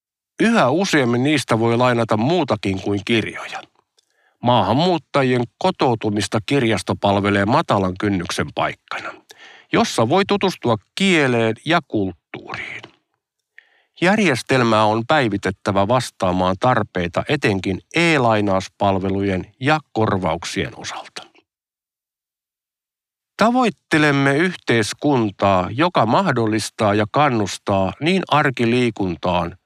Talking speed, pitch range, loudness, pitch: 80 wpm, 100-140 Hz, -18 LUFS, 115 Hz